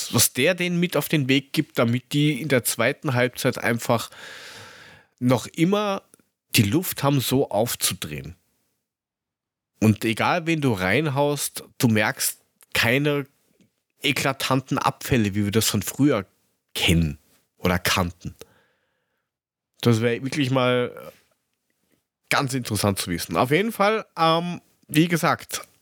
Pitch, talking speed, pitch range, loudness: 130 Hz, 125 wpm, 110-150 Hz, -22 LUFS